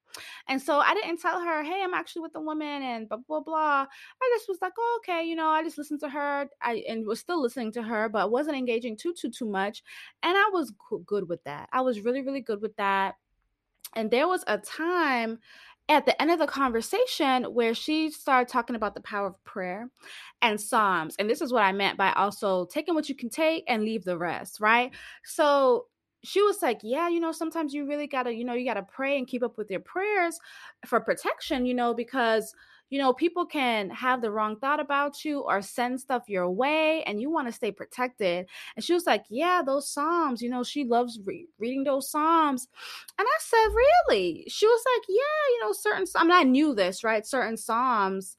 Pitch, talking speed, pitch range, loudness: 270 Hz, 220 wpm, 225-330 Hz, -27 LUFS